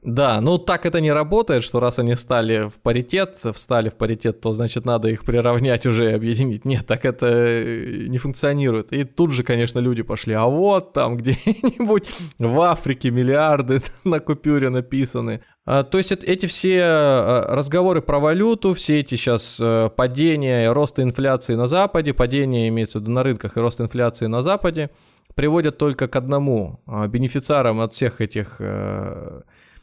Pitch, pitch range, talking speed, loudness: 130 Hz, 115-150 Hz, 160 wpm, -20 LUFS